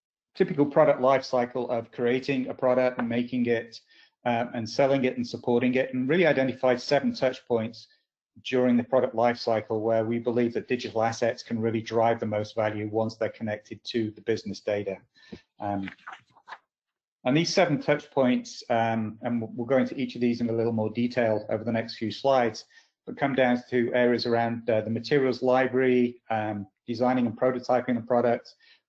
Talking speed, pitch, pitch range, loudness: 180 wpm, 120 Hz, 115-130 Hz, -26 LUFS